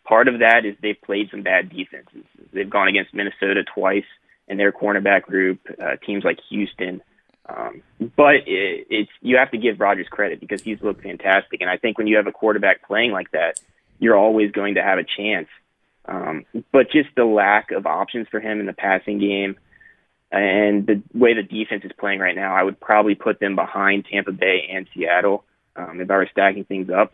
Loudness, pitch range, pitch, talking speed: -19 LUFS, 95-115 Hz, 105 Hz, 205 wpm